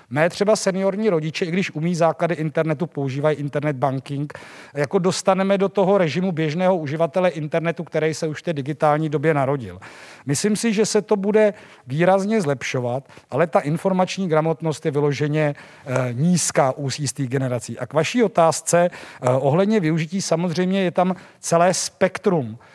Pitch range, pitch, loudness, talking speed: 150-190 Hz, 165 Hz, -21 LUFS, 150 wpm